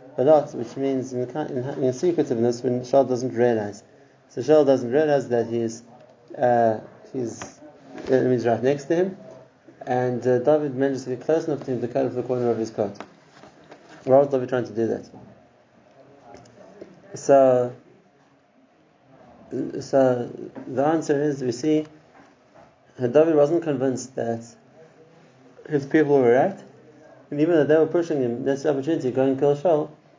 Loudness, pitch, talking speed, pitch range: -22 LUFS, 130 Hz, 165 wpm, 125-150 Hz